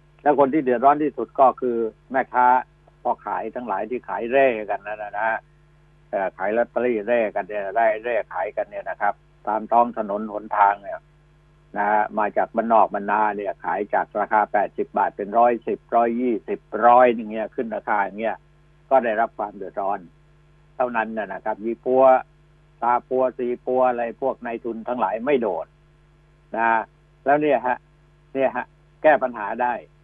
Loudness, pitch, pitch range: -22 LUFS, 125 Hz, 115-150 Hz